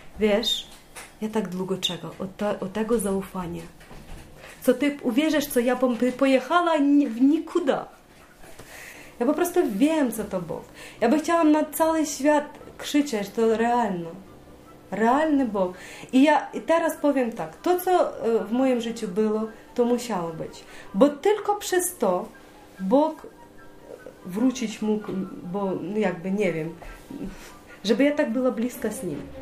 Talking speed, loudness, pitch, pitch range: 145 wpm, -24 LUFS, 240 Hz, 200-295 Hz